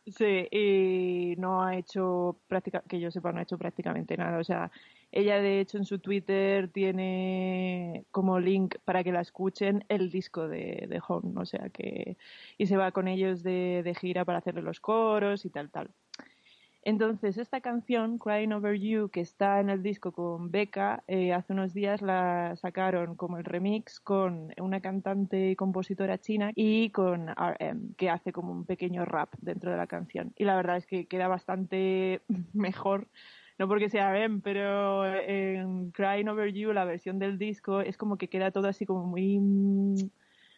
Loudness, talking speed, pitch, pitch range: -31 LUFS, 180 wpm, 190 Hz, 180-200 Hz